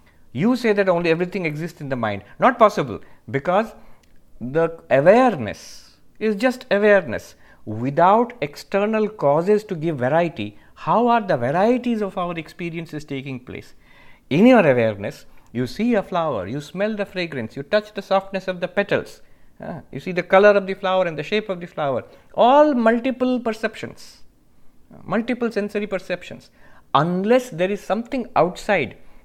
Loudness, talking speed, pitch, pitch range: -20 LUFS, 155 wpm, 185 Hz, 150-215 Hz